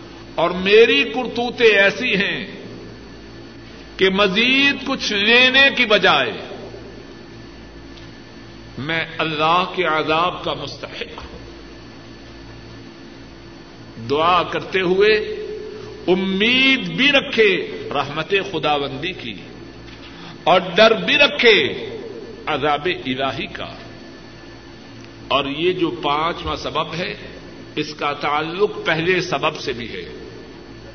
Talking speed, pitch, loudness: 95 wpm, 205 Hz, -17 LUFS